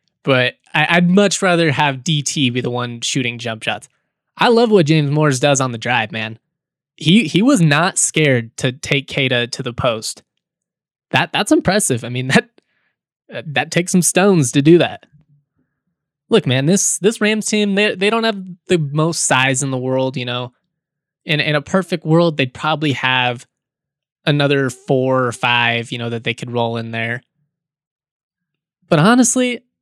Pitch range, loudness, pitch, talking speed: 130-175 Hz, -16 LUFS, 150 Hz, 175 wpm